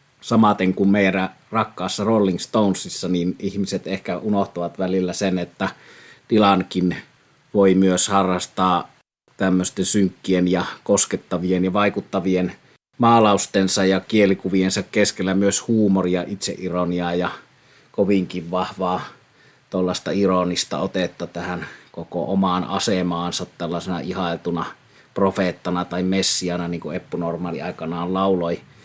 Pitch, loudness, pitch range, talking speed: 95 Hz, -21 LUFS, 90-100 Hz, 105 wpm